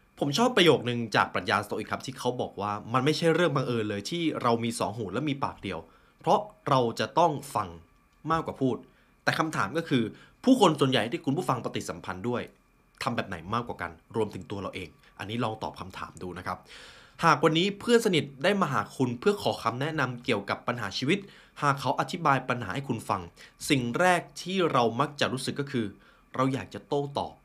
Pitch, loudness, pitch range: 130 Hz, -28 LUFS, 105-160 Hz